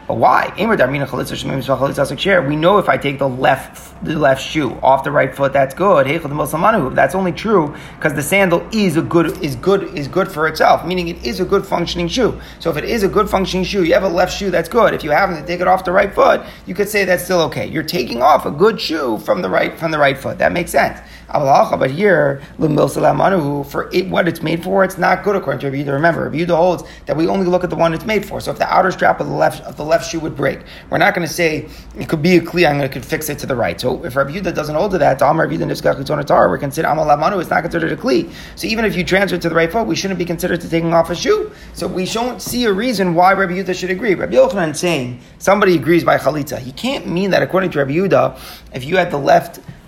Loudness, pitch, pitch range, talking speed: -16 LUFS, 170 Hz, 150-185 Hz, 255 wpm